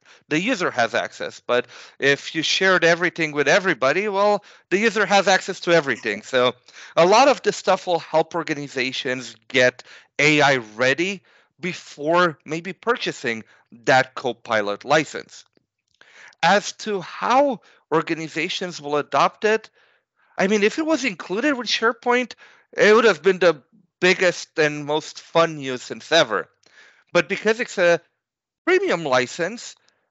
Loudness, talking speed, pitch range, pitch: -20 LUFS, 140 wpm, 145-200 Hz, 175 Hz